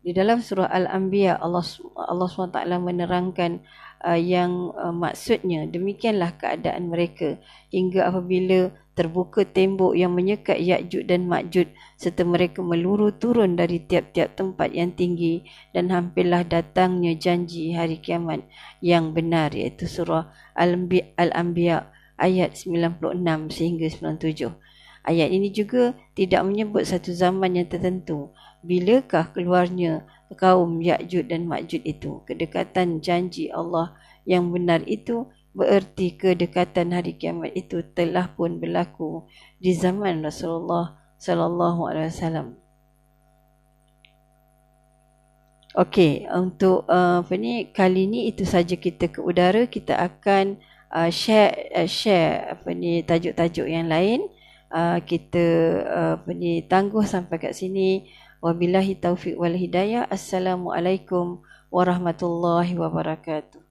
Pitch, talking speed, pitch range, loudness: 175 Hz, 115 wpm, 170-185 Hz, -23 LUFS